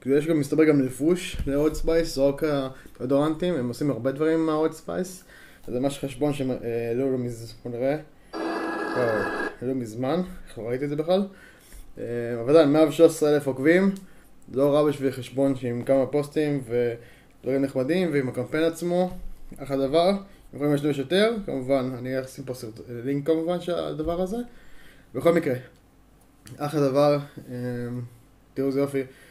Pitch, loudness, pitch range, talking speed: 140 Hz, -25 LUFS, 130-160 Hz, 135 wpm